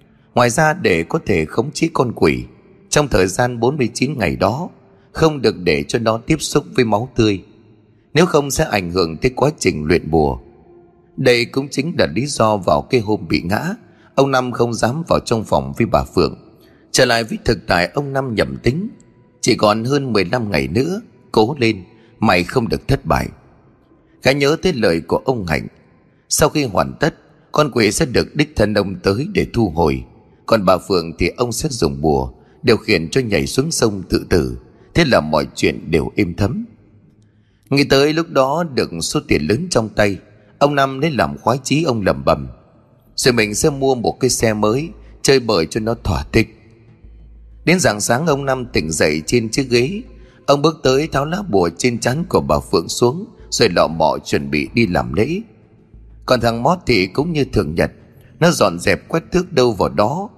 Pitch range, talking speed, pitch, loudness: 105-140 Hz, 200 wpm, 120 Hz, -17 LUFS